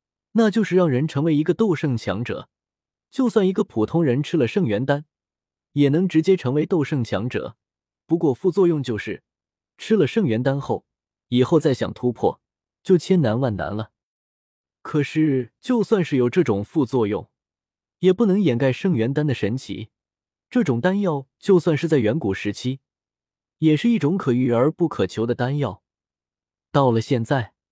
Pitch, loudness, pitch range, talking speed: 145 Hz, -21 LUFS, 120-180 Hz, 240 characters per minute